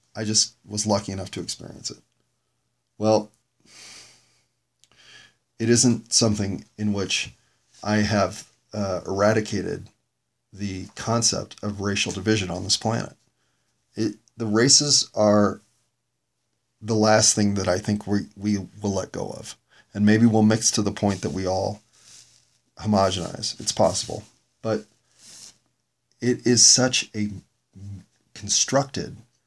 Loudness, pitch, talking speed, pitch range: -22 LUFS, 105 Hz, 125 wpm, 100-115 Hz